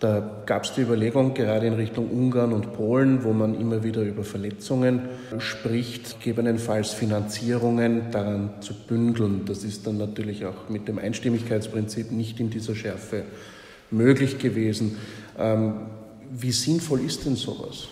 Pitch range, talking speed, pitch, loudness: 105-120 Hz, 140 wpm, 110 Hz, -25 LUFS